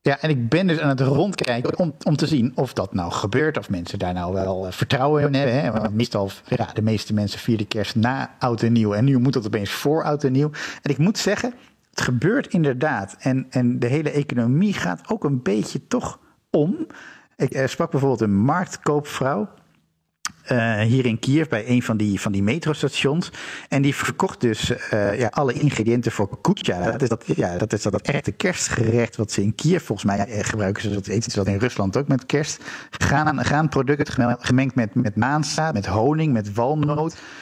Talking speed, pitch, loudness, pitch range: 205 wpm, 125 Hz, -22 LUFS, 110-150 Hz